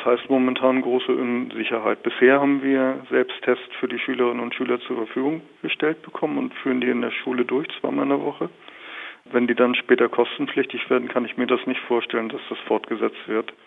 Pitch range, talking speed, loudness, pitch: 120-135 Hz, 200 wpm, -23 LUFS, 125 Hz